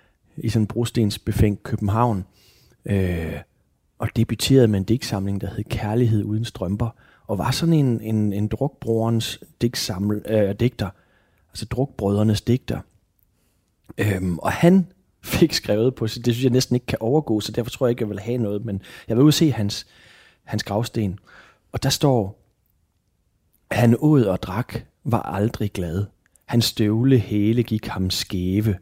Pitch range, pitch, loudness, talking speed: 100-120 Hz, 110 Hz, -22 LUFS, 160 wpm